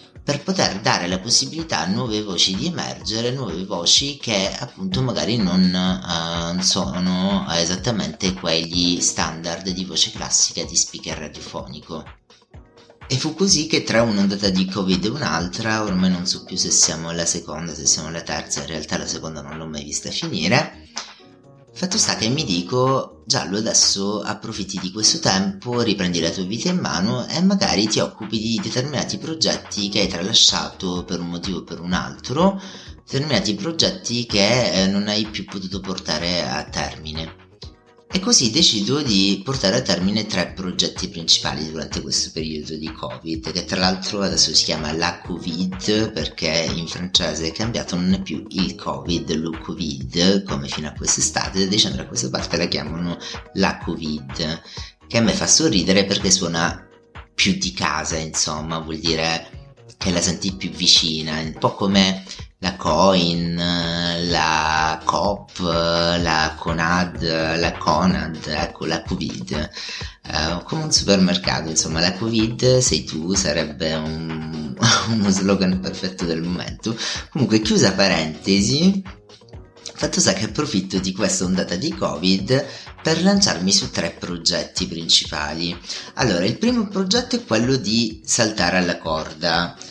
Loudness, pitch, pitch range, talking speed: -20 LUFS, 95 Hz, 80-110 Hz, 150 wpm